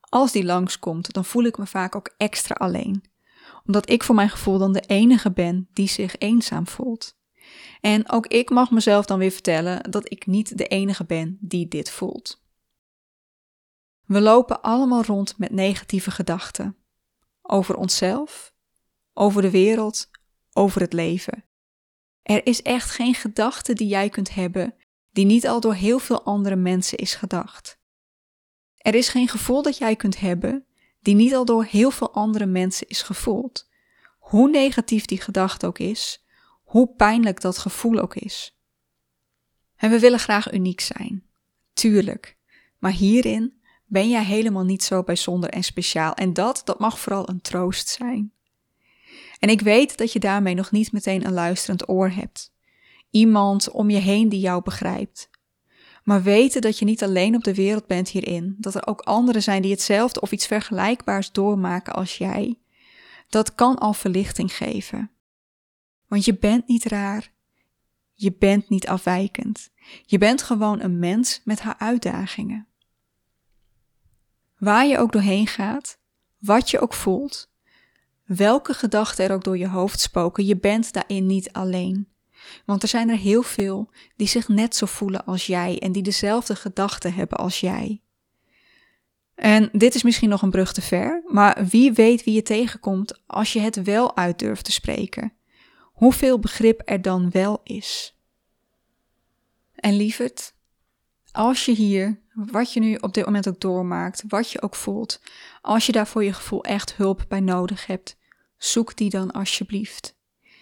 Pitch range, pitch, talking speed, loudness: 190-230 Hz, 205 Hz, 160 wpm, -21 LUFS